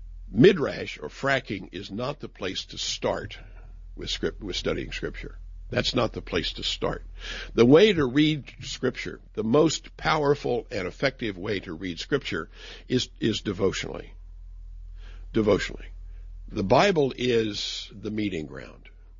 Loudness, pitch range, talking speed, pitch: -26 LUFS, 85-125 Hz, 140 wpm, 100 Hz